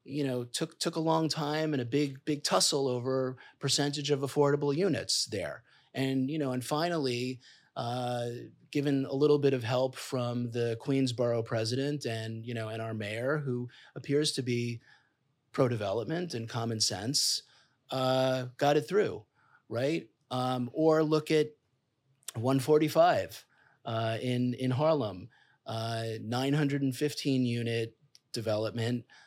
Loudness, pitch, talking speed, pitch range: -31 LUFS, 130 Hz, 150 wpm, 120-145 Hz